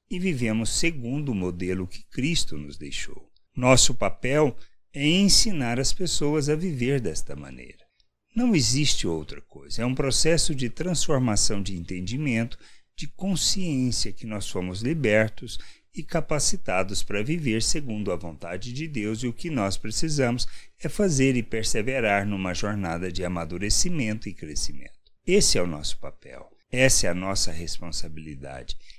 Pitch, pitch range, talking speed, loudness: 115 Hz, 90-150 Hz, 145 wpm, -25 LUFS